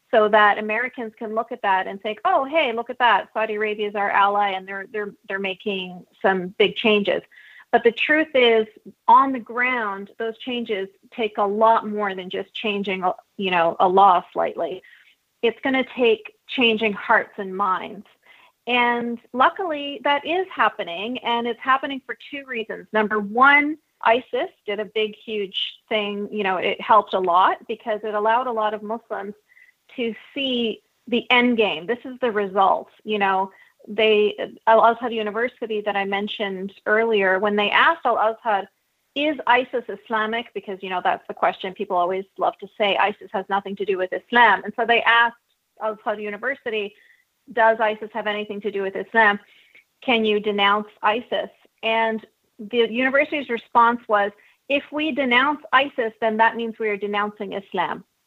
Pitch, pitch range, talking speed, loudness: 220 Hz, 205-245 Hz, 175 wpm, -21 LUFS